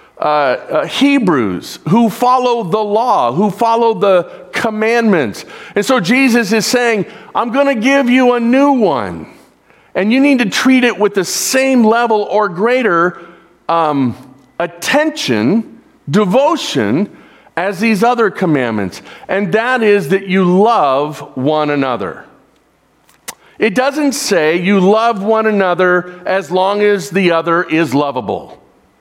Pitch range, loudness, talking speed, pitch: 180-240 Hz, -13 LUFS, 135 wpm, 210 Hz